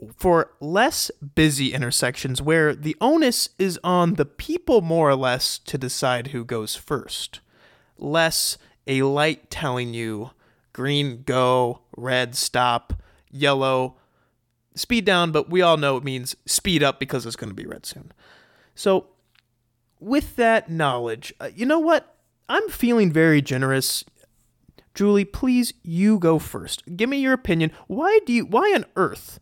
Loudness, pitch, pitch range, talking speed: -21 LUFS, 145 Hz, 125-190 Hz, 145 wpm